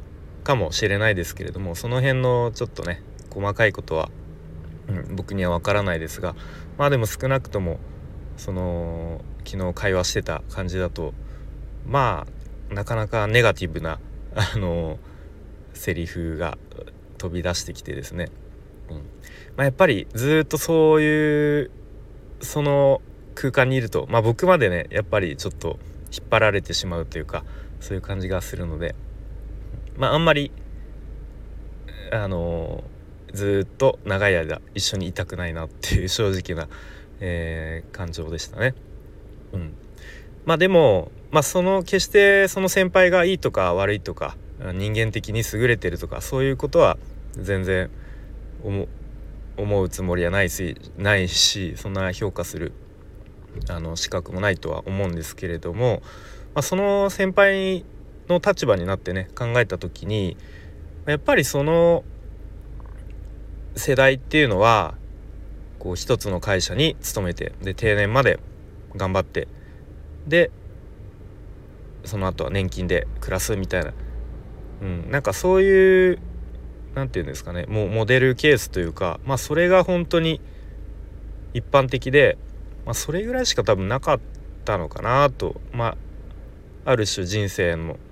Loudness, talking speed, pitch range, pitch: -22 LUFS, 285 characters per minute, 85-120 Hz, 95 Hz